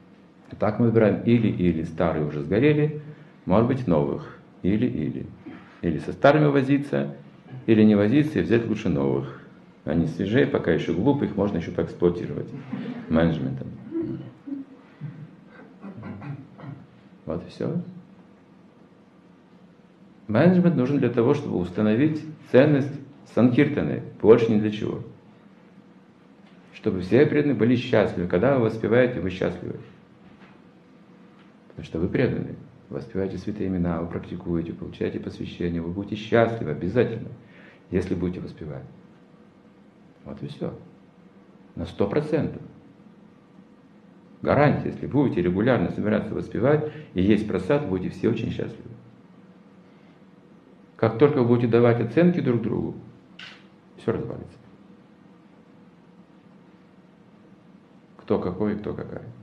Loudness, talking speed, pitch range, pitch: -23 LUFS, 115 wpm, 95-145 Hz, 115 Hz